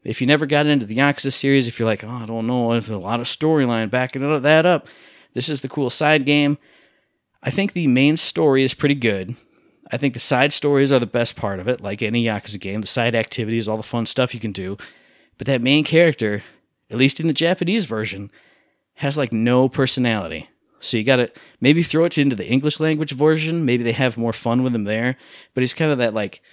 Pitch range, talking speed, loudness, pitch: 115-145 Hz, 230 wpm, -19 LUFS, 130 Hz